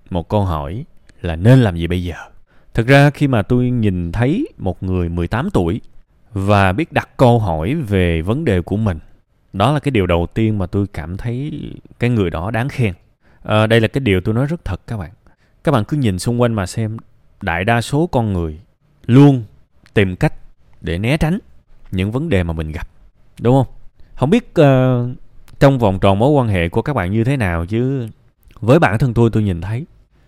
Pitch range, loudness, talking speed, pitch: 95-130 Hz, -16 LUFS, 210 wpm, 110 Hz